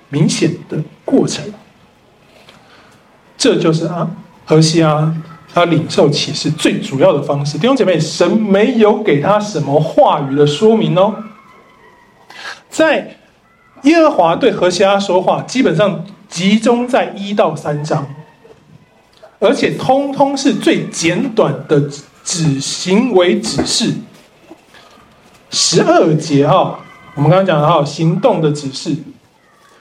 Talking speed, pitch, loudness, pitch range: 185 characters per minute, 175 Hz, -13 LUFS, 155-210 Hz